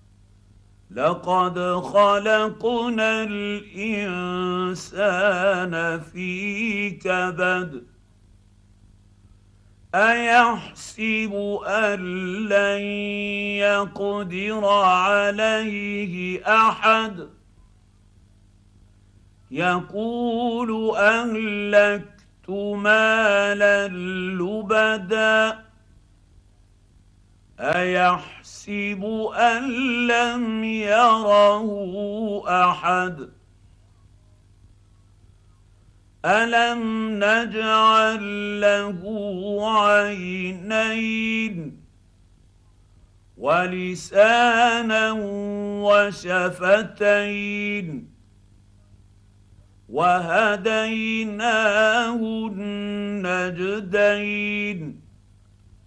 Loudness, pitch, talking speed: -21 LUFS, 200 Hz, 30 wpm